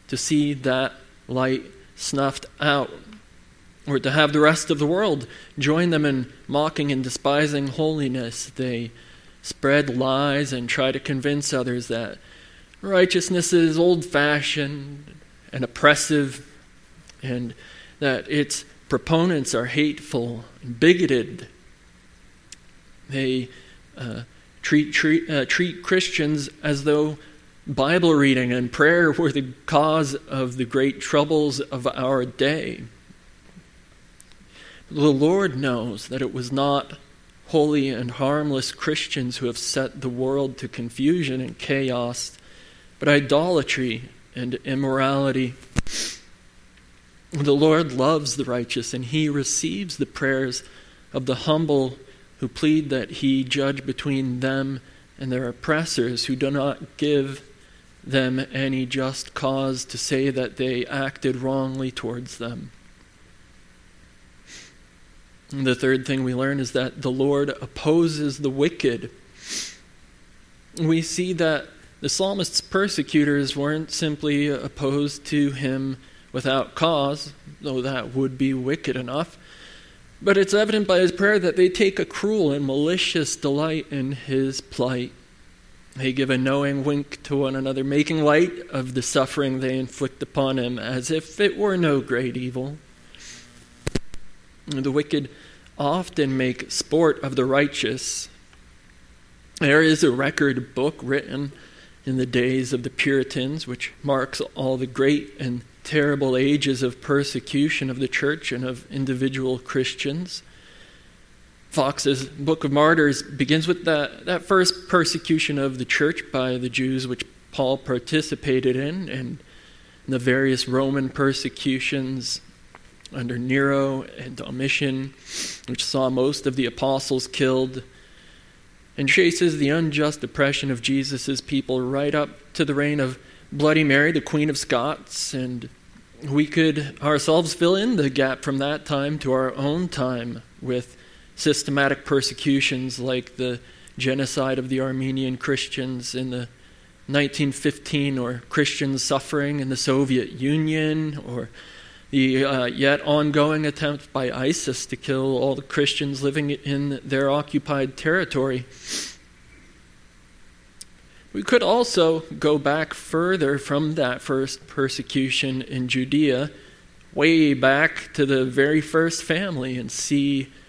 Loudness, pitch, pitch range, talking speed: -23 LUFS, 135 Hz, 130-150 Hz, 130 wpm